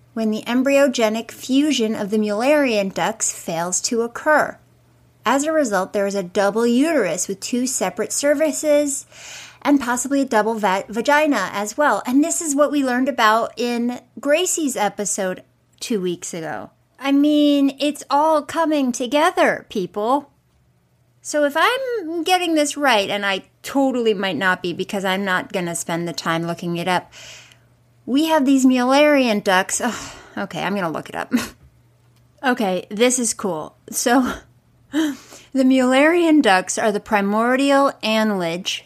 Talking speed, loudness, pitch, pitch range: 150 wpm, -19 LUFS, 240 Hz, 200-285 Hz